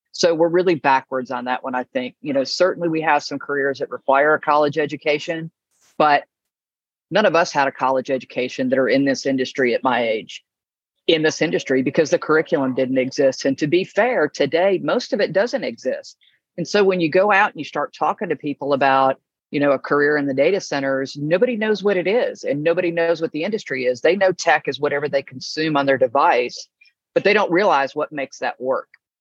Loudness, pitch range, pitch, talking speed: -19 LUFS, 135-170 Hz, 150 Hz, 220 wpm